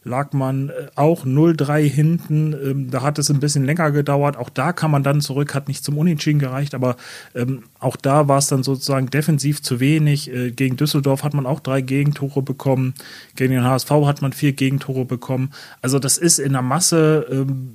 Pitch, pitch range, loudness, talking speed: 140 Hz, 130-150 Hz, -19 LUFS, 185 wpm